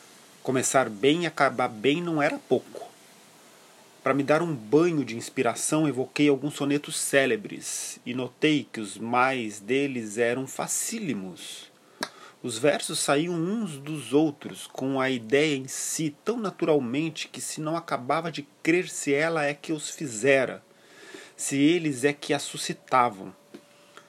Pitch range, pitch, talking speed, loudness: 130-155 Hz, 145 Hz, 145 wpm, -26 LUFS